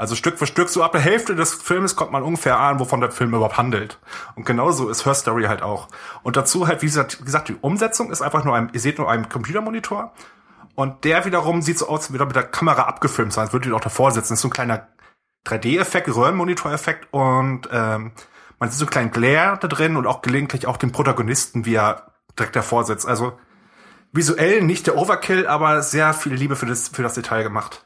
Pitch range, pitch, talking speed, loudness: 120-160 Hz, 135 Hz, 225 wpm, -19 LUFS